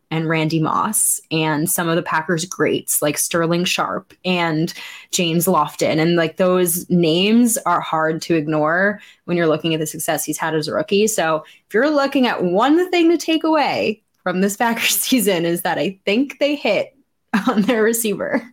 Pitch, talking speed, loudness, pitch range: 185 Hz, 185 wpm, -18 LUFS, 165-230 Hz